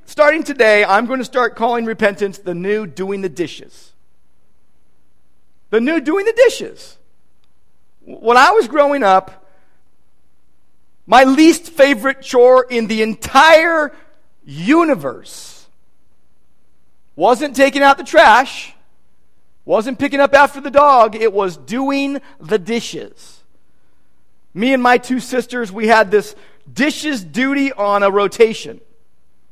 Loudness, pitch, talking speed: -13 LUFS, 220 Hz, 120 wpm